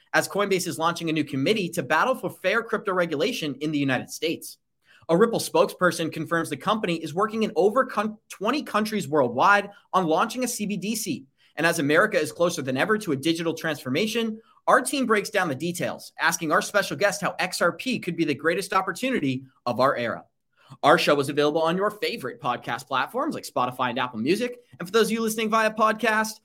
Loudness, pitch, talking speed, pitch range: -24 LUFS, 185 Hz, 195 wpm, 160-220 Hz